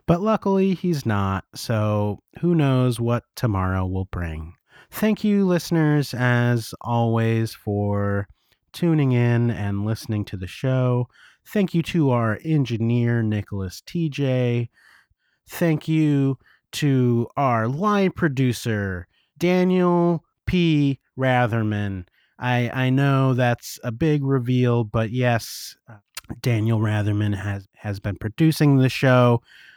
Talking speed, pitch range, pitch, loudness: 115 wpm, 110-150 Hz, 120 Hz, -22 LUFS